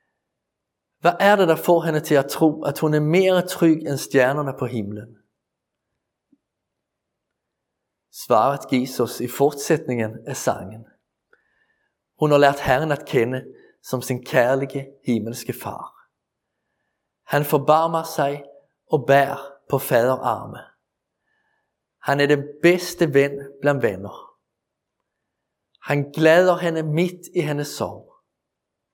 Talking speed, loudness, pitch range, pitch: 120 wpm, -20 LUFS, 130-155 Hz, 140 Hz